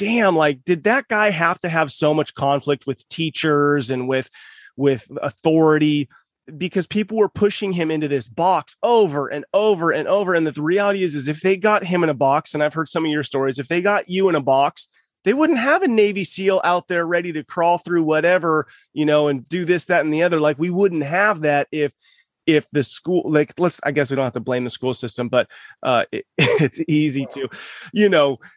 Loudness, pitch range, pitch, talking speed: -19 LUFS, 145-180 Hz, 160 Hz, 225 wpm